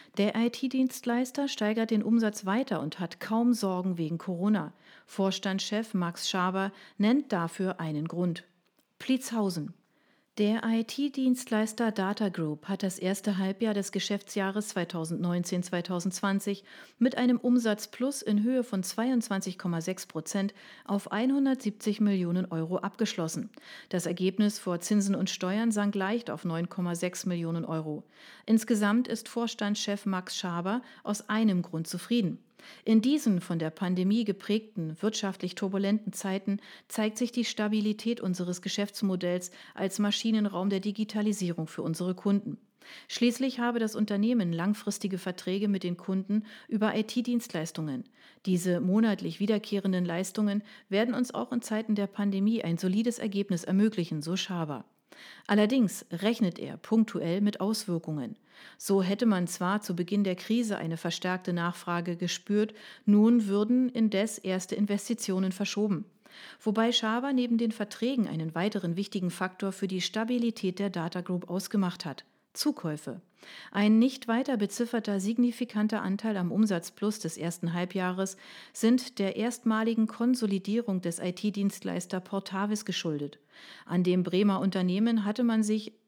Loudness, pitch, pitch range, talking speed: -30 LUFS, 205 Hz, 185-220 Hz, 130 wpm